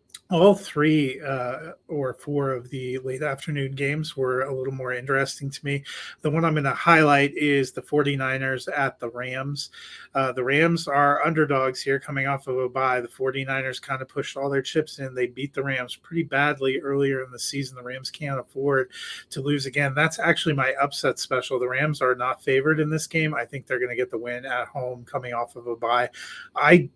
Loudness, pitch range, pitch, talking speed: -24 LUFS, 130-145 Hz, 135 Hz, 210 wpm